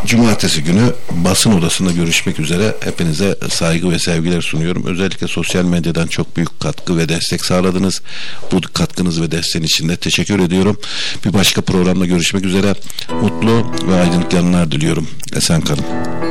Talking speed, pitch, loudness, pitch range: 145 wpm, 90 Hz, -15 LUFS, 85-95 Hz